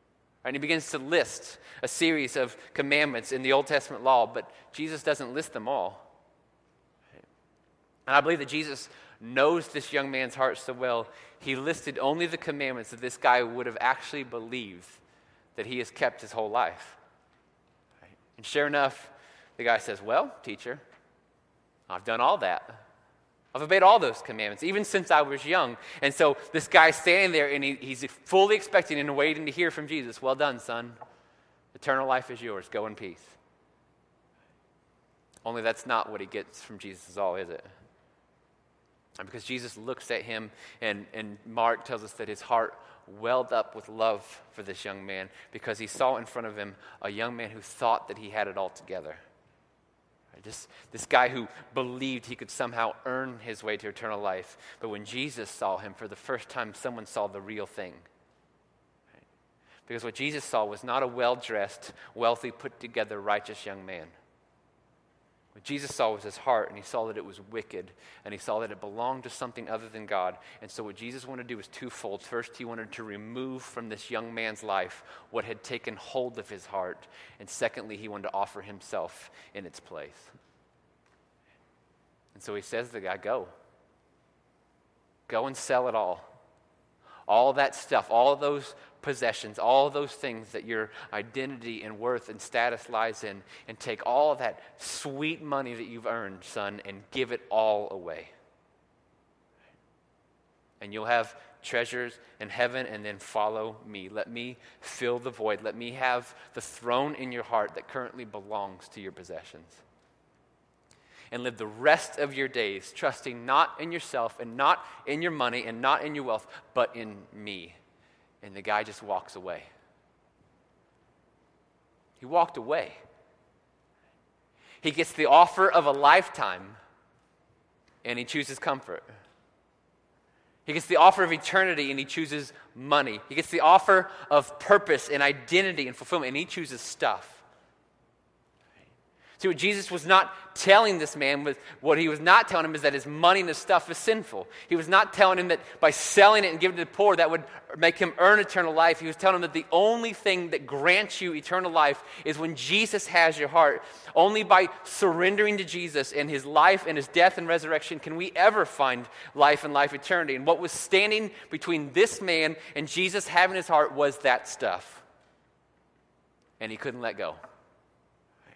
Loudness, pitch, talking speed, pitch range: -27 LUFS, 135 Hz, 180 wpm, 115-160 Hz